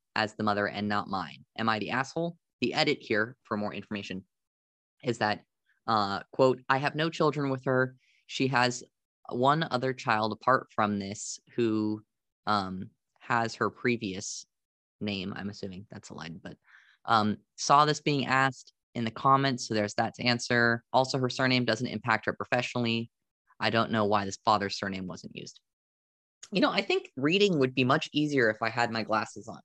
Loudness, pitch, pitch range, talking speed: -29 LUFS, 115 Hz, 105-130 Hz, 180 wpm